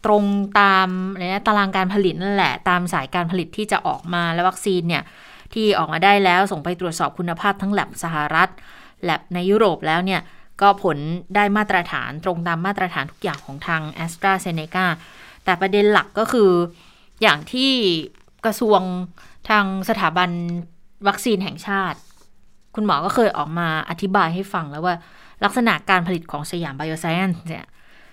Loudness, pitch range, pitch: -20 LUFS, 170-200 Hz, 185 Hz